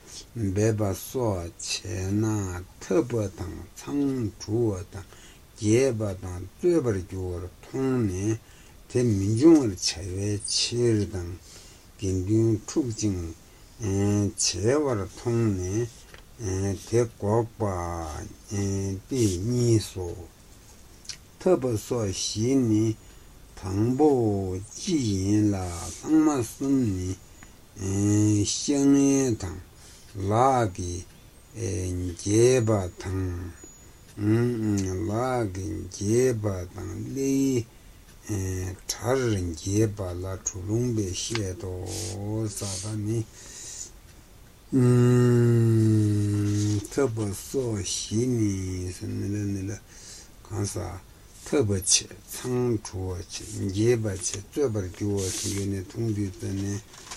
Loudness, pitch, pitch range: -26 LUFS, 105 Hz, 95-115 Hz